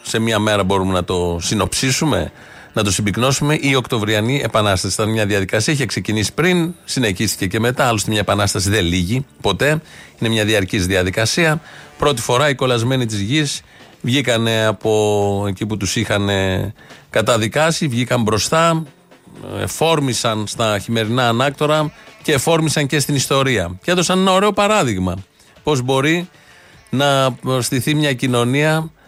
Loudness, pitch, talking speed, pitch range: -17 LUFS, 120 Hz, 140 wpm, 105-150 Hz